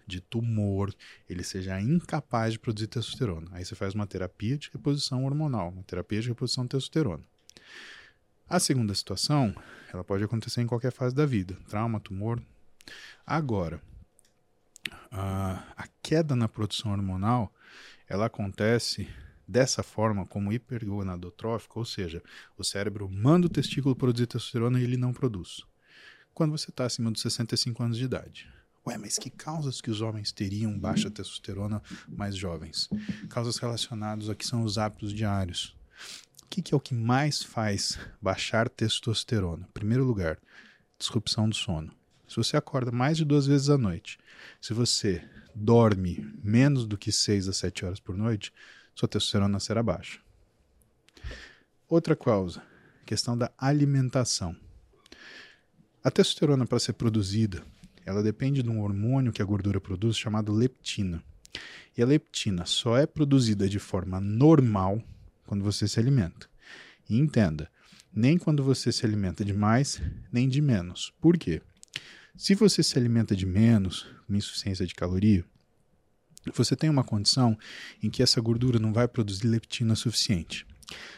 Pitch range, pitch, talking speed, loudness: 100-125 Hz, 110 Hz, 150 wpm, -28 LUFS